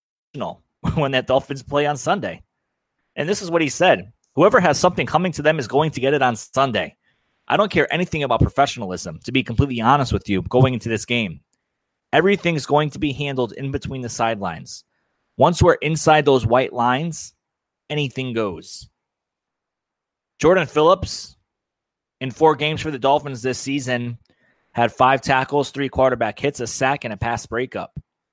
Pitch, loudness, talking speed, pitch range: 135 Hz, -19 LUFS, 170 wpm, 125-150 Hz